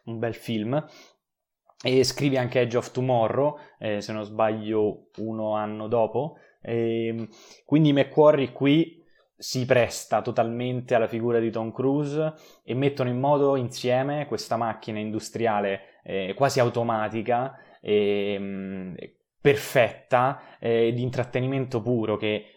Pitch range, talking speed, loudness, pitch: 110-130 Hz, 125 wpm, -25 LUFS, 120 Hz